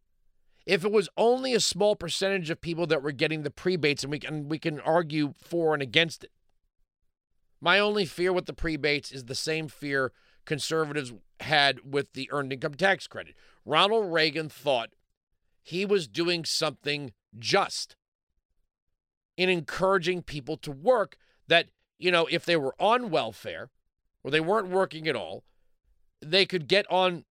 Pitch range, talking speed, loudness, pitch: 140-180 Hz, 160 wpm, -27 LUFS, 160 Hz